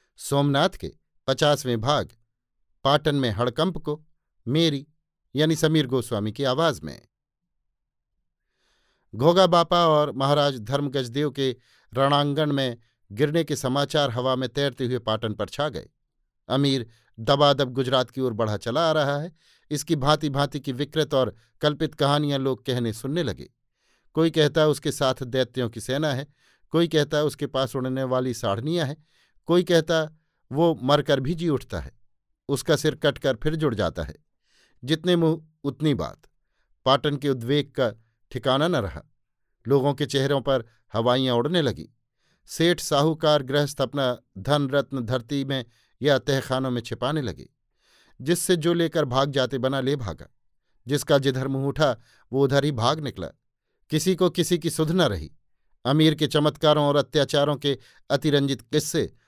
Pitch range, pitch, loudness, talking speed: 130-150 Hz, 140 Hz, -24 LUFS, 150 wpm